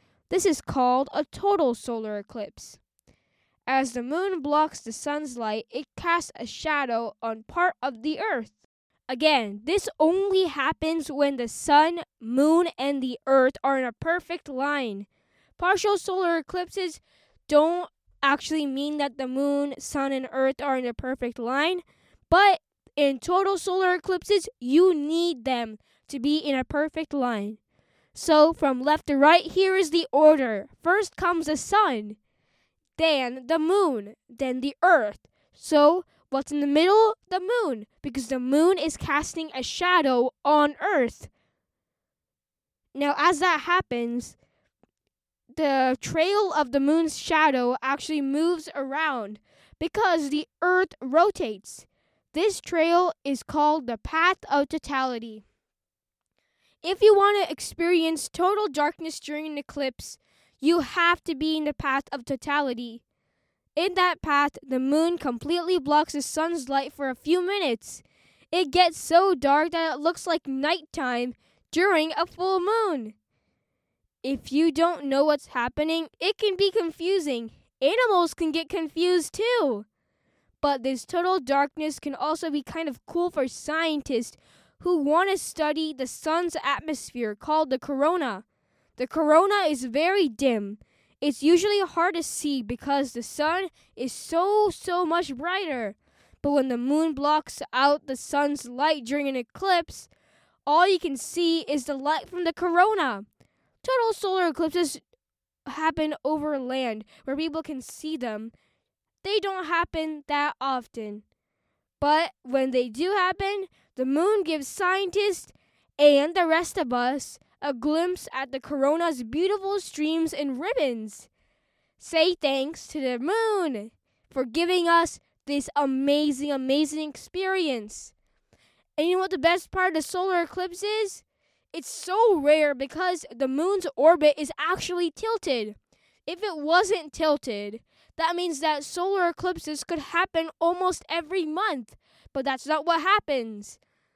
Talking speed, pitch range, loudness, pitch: 145 wpm, 270-350 Hz, -25 LUFS, 310 Hz